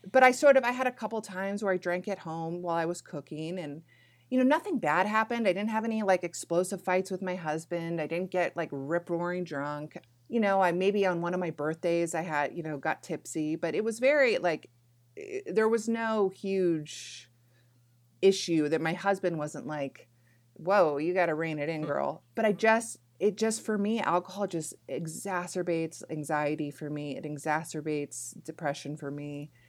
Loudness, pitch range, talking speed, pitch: -30 LUFS, 150-195 Hz, 200 wpm, 170 Hz